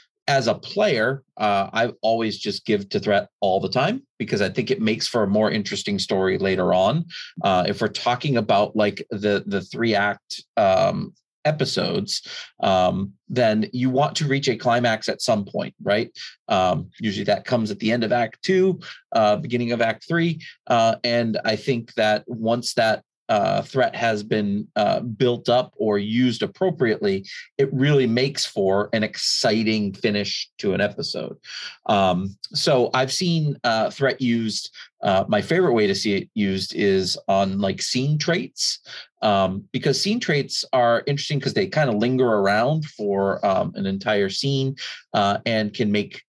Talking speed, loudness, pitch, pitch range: 170 wpm, -22 LUFS, 115 Hz, 105-135 Hz